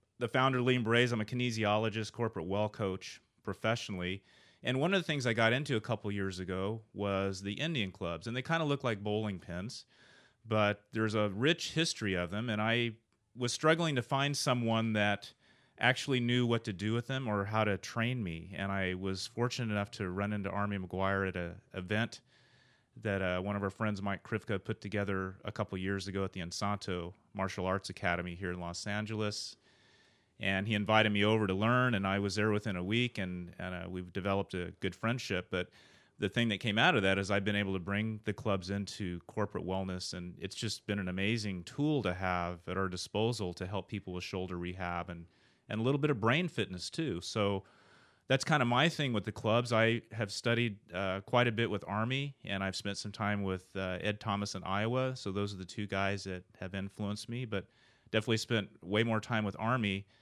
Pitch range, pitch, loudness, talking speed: 95-115 Hz, 105 Hz, -34 LUFS, 215 wpm